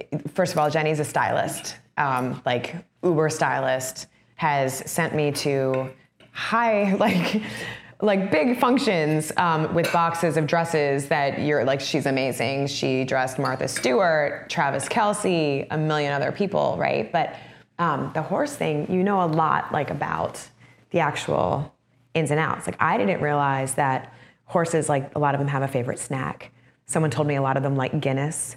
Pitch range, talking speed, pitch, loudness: 135-170 Hz, 170 wpm, 150 Hz, -23 LUFS